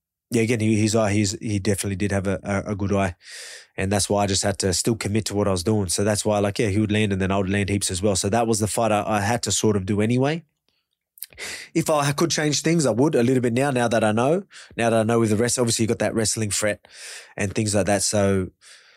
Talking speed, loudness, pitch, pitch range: 295 wpm, -22 LUFS, 105 Hz, 100-115 Hz